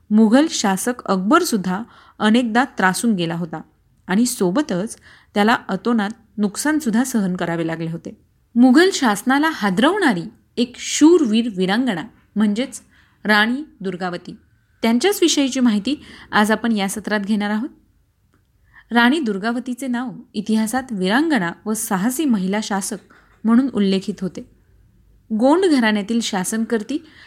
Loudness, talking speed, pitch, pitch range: -19 LUFS, 110 wpm, 225 Hz, 200-255 Hz